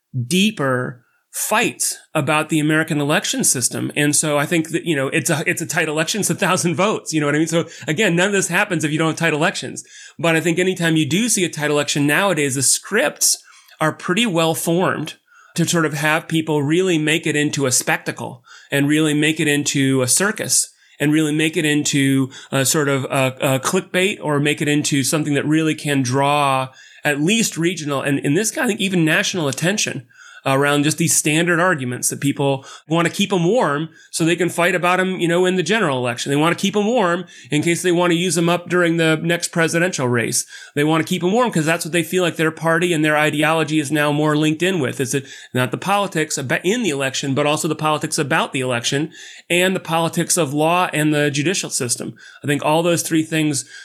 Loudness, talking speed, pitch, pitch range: -18 LUFS, 225 wpm, 160 Hz, 145-175 Hz